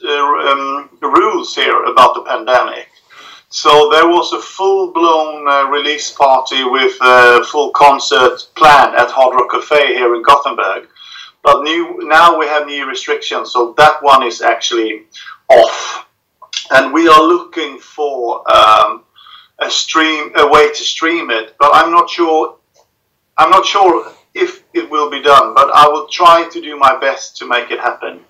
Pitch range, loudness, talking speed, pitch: 140-170 Hz, -10 LUFS, 165 wpm, 150 Hz